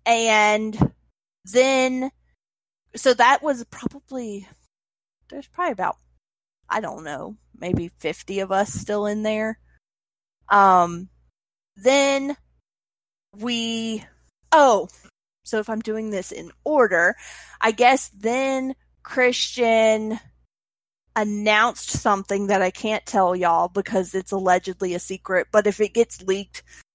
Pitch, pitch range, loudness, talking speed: 215 Hz, 195-240 Hz, -21 LUFS, 115 wpm